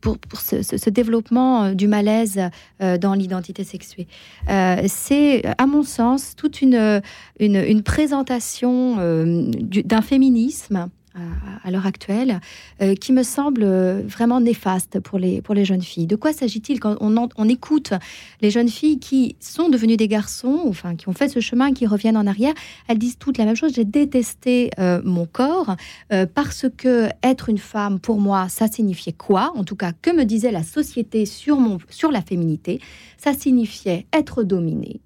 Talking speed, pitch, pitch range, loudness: 180 wpm, 220 Hz, 195-255 Hz, -19 LUFS